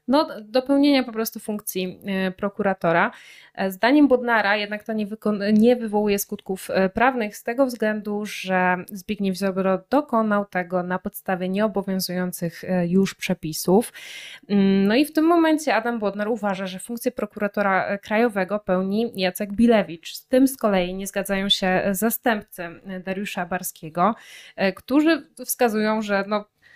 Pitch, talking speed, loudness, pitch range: 205 Hz, 125 wpm, -22 LUFS, 190-235 Hz